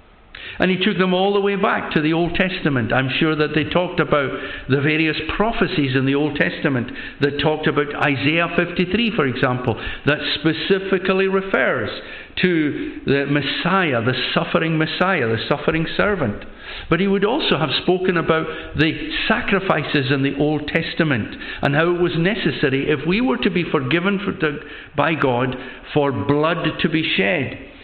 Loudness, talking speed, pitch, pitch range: -19 LUFS, 165 wpm, 160 Hz, 145-185 Hz